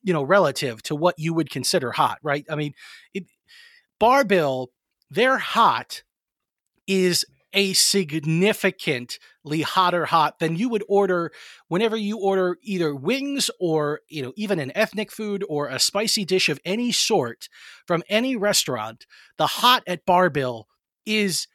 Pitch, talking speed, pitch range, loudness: 185 Hz, 140 wpm, 155-210 Hz, -22 LUFS